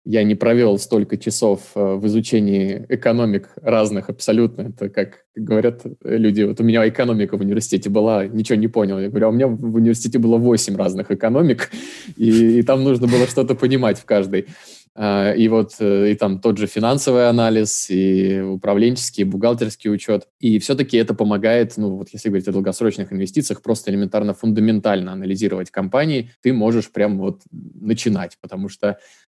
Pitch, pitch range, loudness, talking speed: 110 Hz, 100-115 Hz, -18 LUFS, 165 wpm